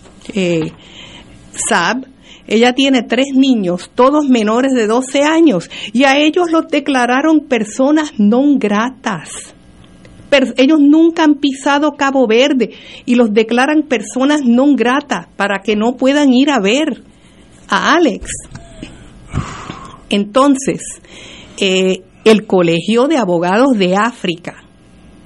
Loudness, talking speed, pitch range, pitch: -13 LUFS, 115 wpm, 215-280 Hz, 250 Hz